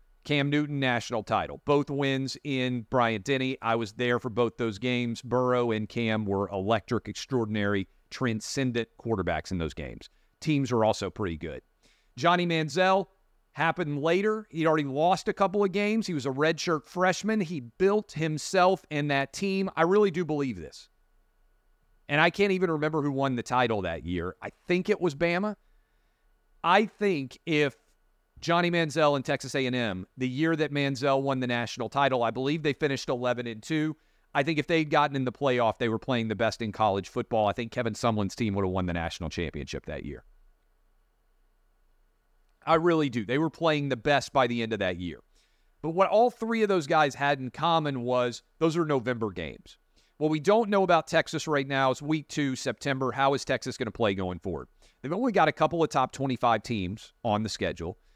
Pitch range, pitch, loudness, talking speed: 115-160 Hz, 135 Hz, -28 LUFS, 190 wpm